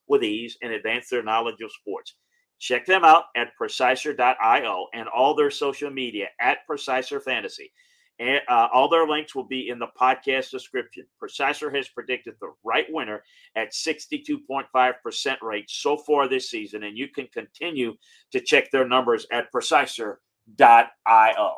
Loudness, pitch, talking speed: -22 LUFS, 150 Hz, 155 wpm